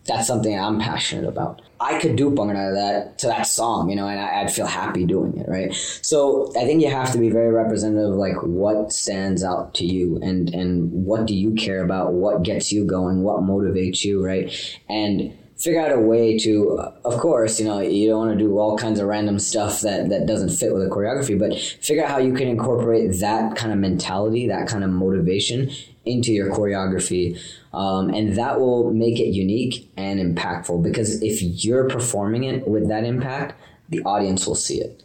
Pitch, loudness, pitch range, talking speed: 105 Hz, -21 LUFS, 95-115 Hz, 210 wpm